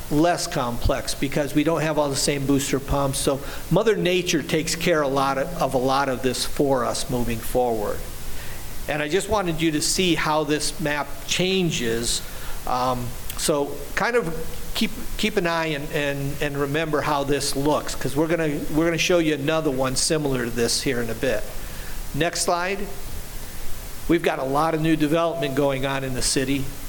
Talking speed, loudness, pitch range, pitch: 185 wpm, -23 LUFS, 135-165 Hz, 145 Hz